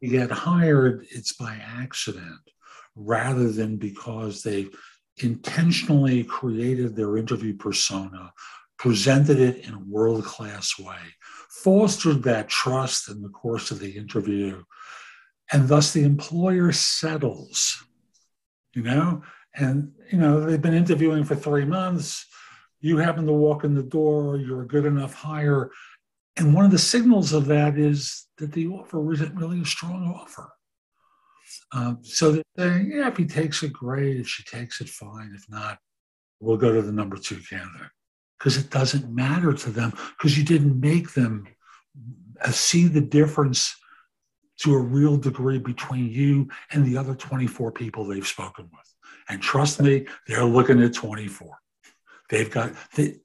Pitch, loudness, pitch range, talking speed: 135 Hz, -23 LUFS, 115-155 Hz, 155 wpm